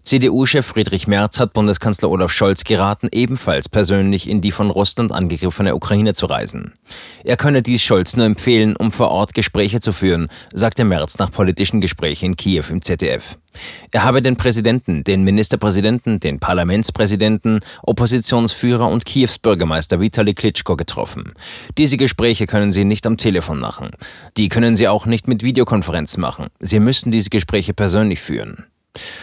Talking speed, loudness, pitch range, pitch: 155 wpm, -16 LUFS, 95-115 Hz, 105 Hz